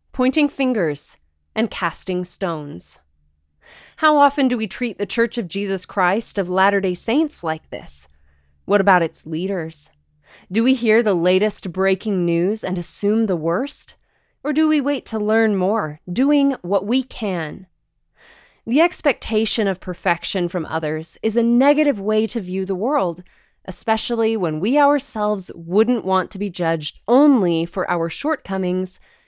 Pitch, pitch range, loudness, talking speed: 200 Hz, 175-235 Hz, -19 LUFS, 150 wpm